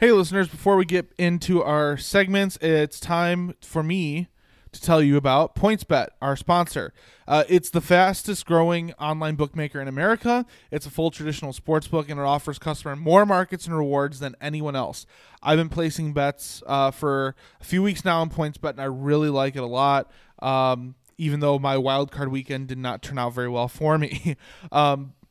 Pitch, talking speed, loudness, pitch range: 150 Hz, 185 wpm, -23 LUFS, 140-175 Hz